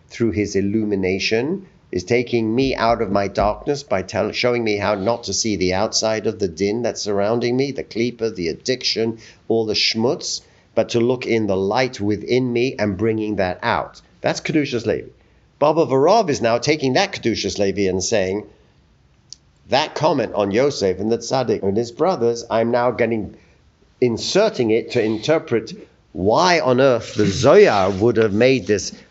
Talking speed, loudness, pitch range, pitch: 175 wpm, -19 LUFS, 100-120 Hz, 115 Hz